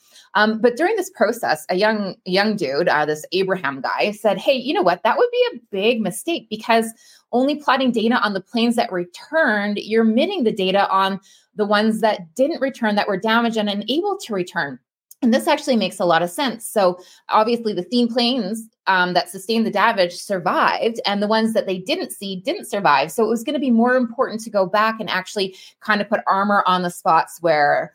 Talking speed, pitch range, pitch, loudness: 215 wpm, 190-245 Hz, 215 Hz, -19 LUFS